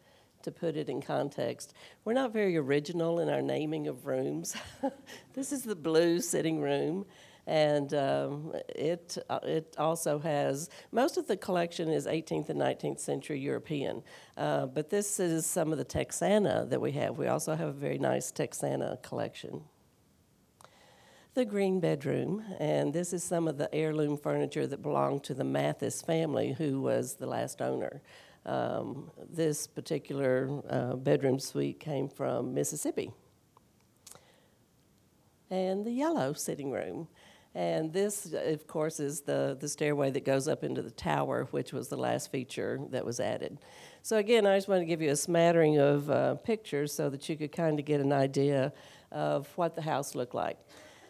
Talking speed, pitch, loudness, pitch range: 165 wpm, 155 Hz, -32 LUFS, 140-180 Hz